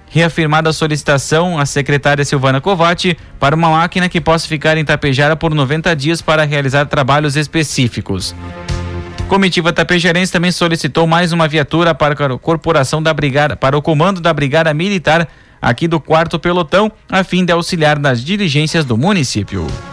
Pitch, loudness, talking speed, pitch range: 155 Hz, -13 LUFS, 155 wpm, 145-170 Hz